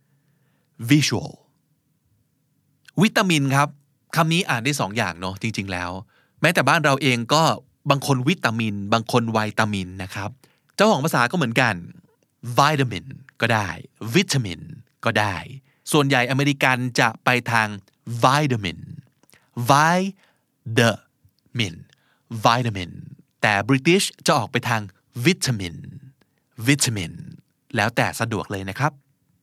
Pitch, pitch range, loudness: 135 Hz, 115-145 Hz, -21 LUFS